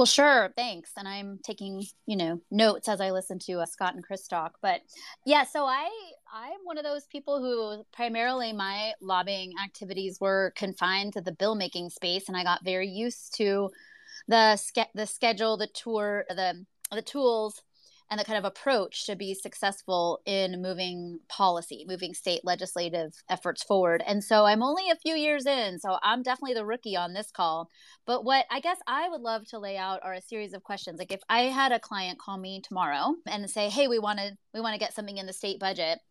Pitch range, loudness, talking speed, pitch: 185-230 Hz, -29 LUFS, 205 wpm, 200 Hz